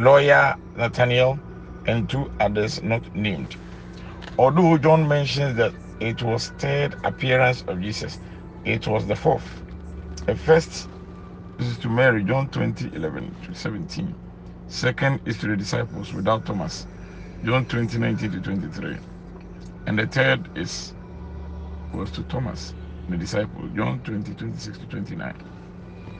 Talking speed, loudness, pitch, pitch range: 130 wpm, -23 LUFS, 95 Hz, 90-125 Hz